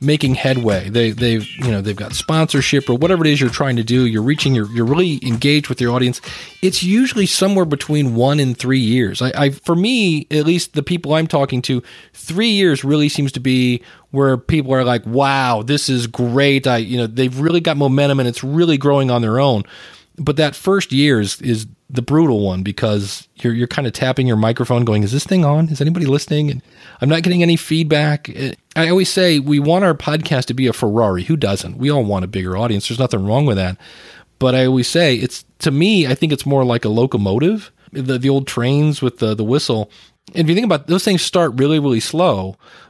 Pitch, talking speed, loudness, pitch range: 135 Hz, 230 wpm, -16 LUFS, 120-155 Hz